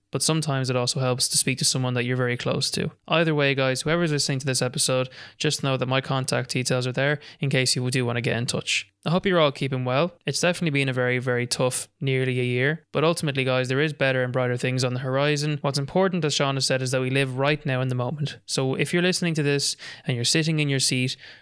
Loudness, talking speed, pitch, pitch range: -23 LUFS, 265 wpm, 135 Hz, 130-150 Hz